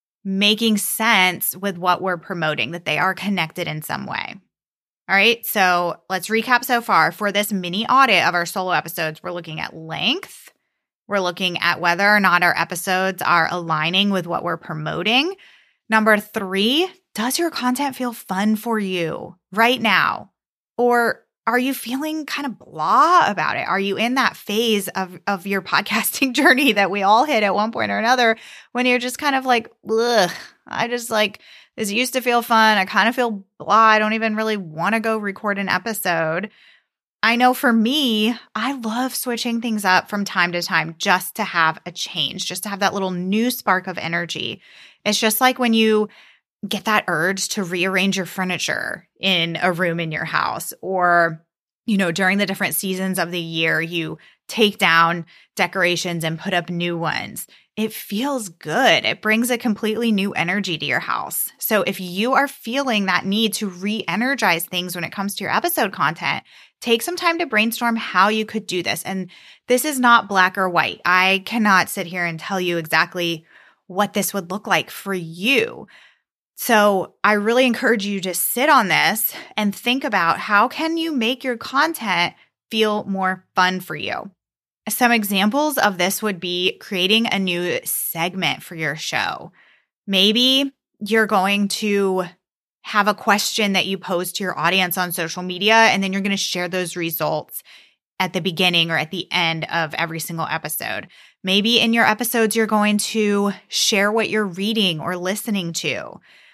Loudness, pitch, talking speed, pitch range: -19 LUFS, 200 Hz, 185 wpm, 180-225 Hz